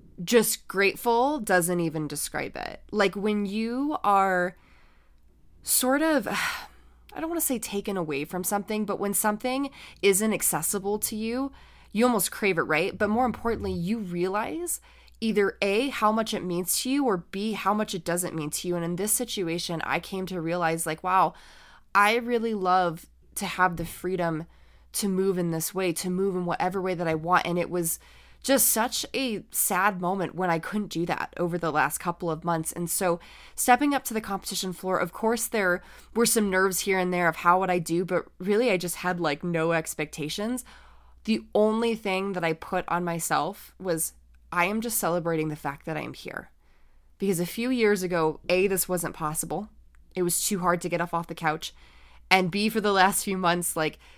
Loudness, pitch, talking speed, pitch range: -26 LUFS, 185 Hz, 200 wpm, 170-210 Hz